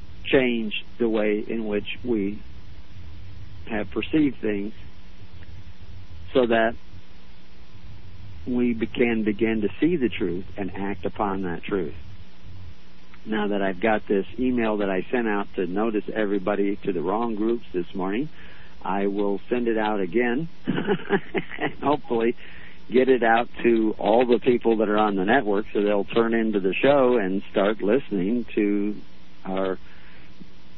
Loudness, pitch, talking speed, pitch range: -24 LUFS, 100 Hz, 140 wpm, 95-115 Hz